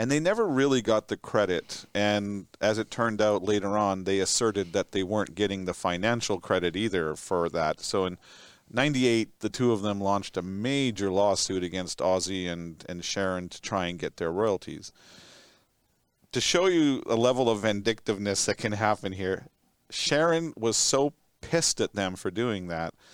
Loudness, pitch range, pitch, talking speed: -27 LUFS, 95-115 Hz, 105 Hz, 175 wpm